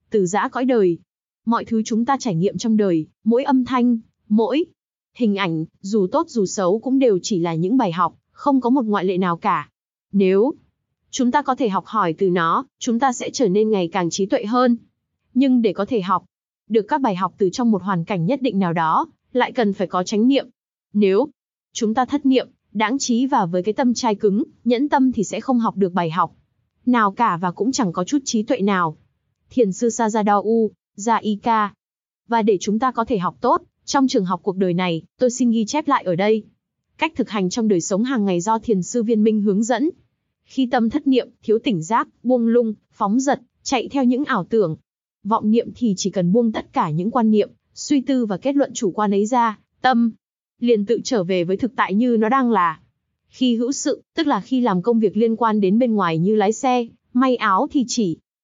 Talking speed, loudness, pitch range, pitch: 225 wpm, -20 LUFS, 195-250 Hz, 225 Hz